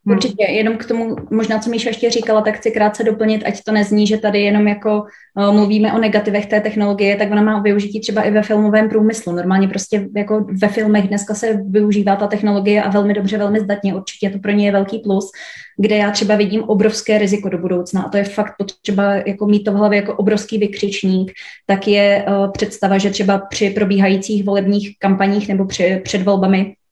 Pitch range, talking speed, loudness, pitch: 200-215 Hz, 205 wpm, -16 LUFS, 205 Hz